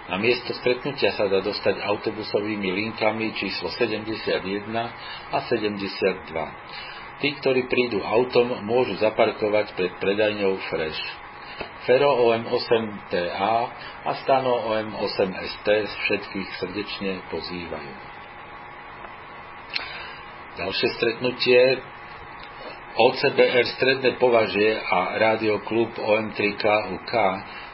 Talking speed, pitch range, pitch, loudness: 80 wpm, 100-120 Hz, 110 Hz, -23 LUFS